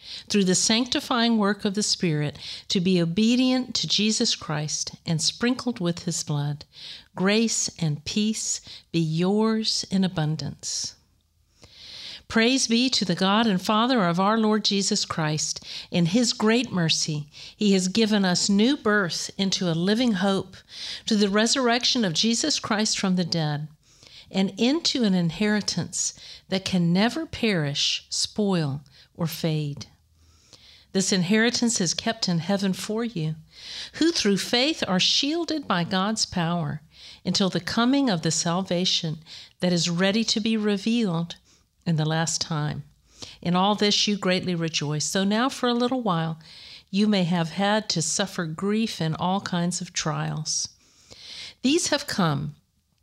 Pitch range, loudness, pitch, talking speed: 165-220 Hz, -24 LUFS, 190 Hz, 145 wpm